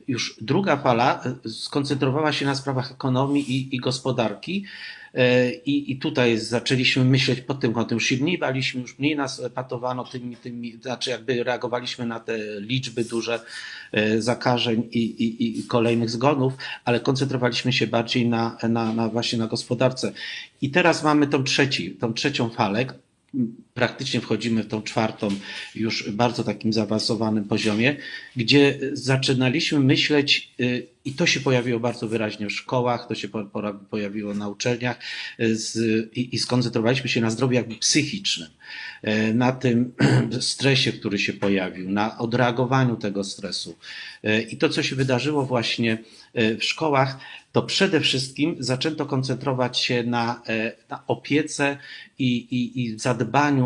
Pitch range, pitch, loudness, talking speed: 115-135 Hz, 125 Hz, -23 LUFS, 135 wpm